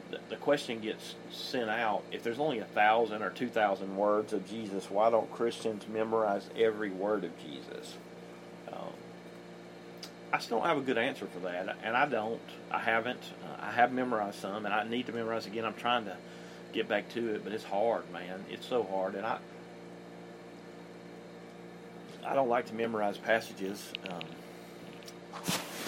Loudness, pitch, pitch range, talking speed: -33 LUFS, 110 Hz, 100-115 Hz, 165 wpm